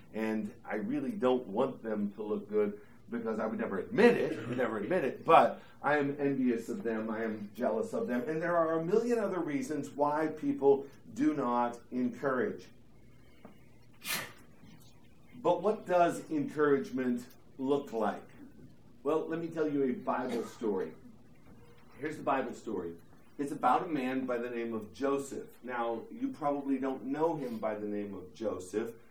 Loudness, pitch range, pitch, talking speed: -33 LUFS, 115-165 Hz, 135 Hz, 165 wpm